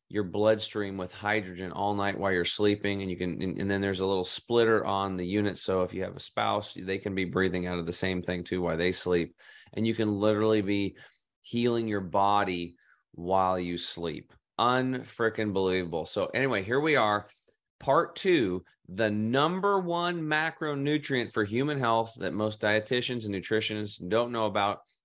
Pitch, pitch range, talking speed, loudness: 105 Hz, 95-115 Hz, 180 wpm, -29 LUFS